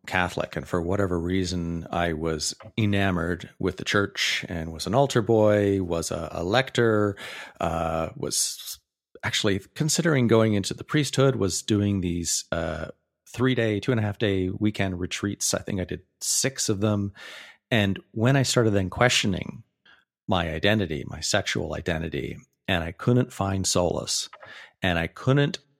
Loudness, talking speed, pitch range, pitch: -25 LUFS, 155 wpm, 90-115 Hz, 100 Hz